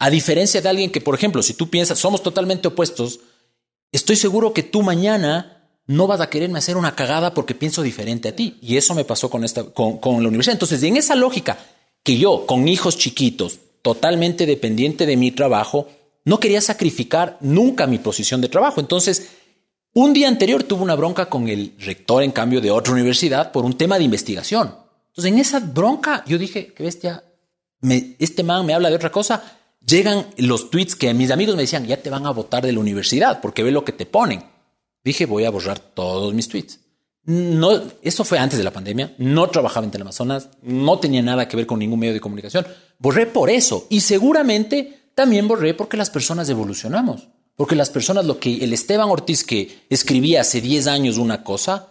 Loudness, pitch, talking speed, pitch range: -18 LUFS, 160 Hz, 200 wpm, 125-190 Hz